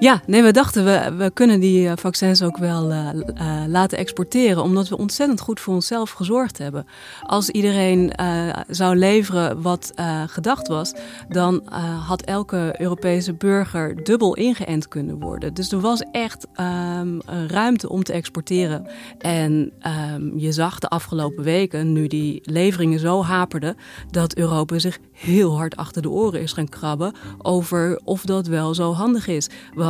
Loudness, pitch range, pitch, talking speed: -20 LUFS, 160-195 Hz, 175 Hz, 165 wpm